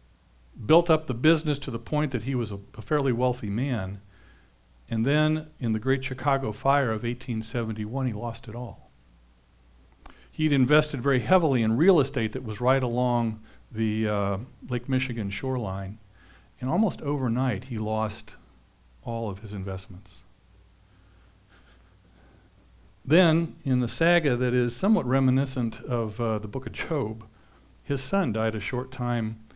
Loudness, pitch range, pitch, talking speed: -26 LUFS, 100-135 Hz, 120 Hz, 150 wpm